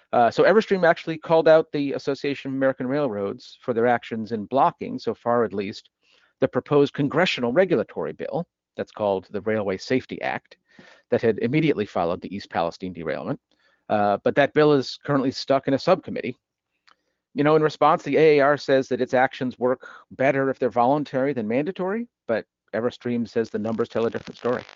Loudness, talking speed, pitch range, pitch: -23 LUFS, 180 wpm, 120-150 Hz, 135 Hz